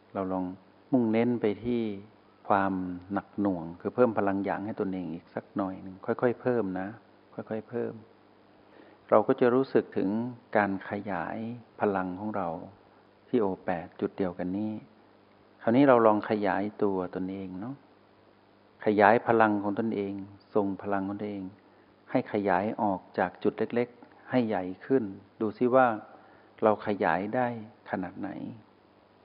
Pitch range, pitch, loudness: 95-110 Hz, 105 Hz, -29 LUFS